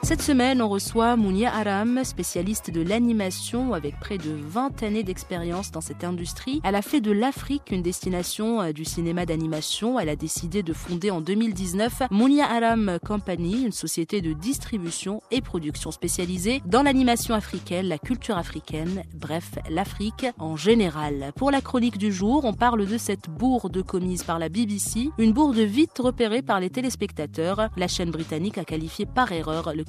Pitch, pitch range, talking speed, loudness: 200 Hz, 170-235 Hz, 170 wpm, -25 LUFS